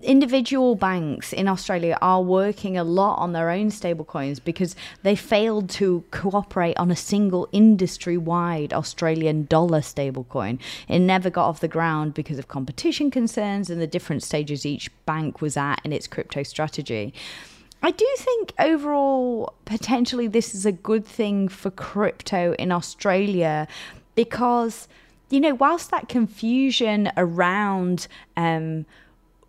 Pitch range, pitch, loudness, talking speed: 160-220 Hz, 180 Hz, -23 LUFS, 140 wpm